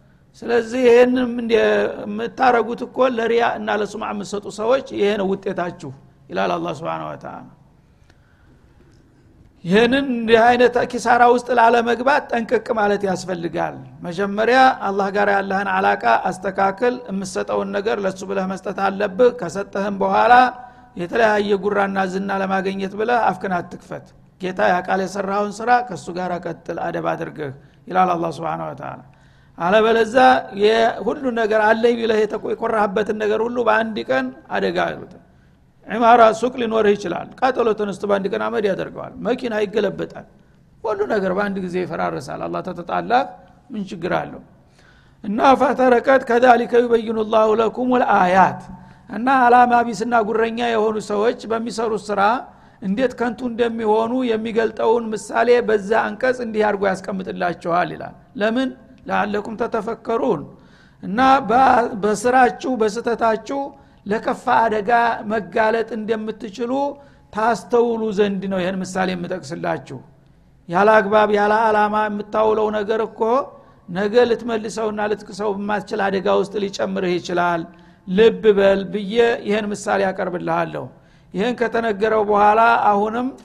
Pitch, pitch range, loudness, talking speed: 215 Hz, 195-235 Hz, -19 LUFS, 110 wpm